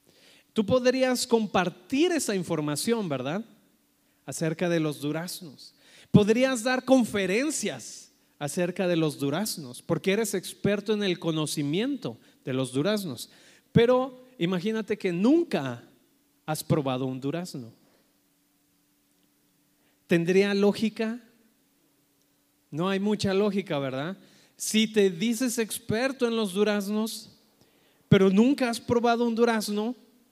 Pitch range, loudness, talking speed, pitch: 165-235 Hz, -26 LUFS, 105 wpm, 205 Hz